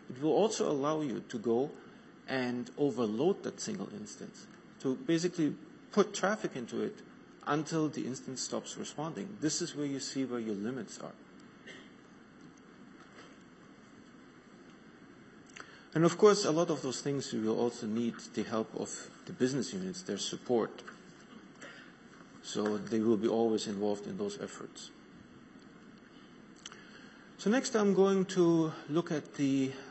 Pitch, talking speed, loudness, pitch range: 145 Hz, 140 wpm, -33 LUFS, 120-180 Hz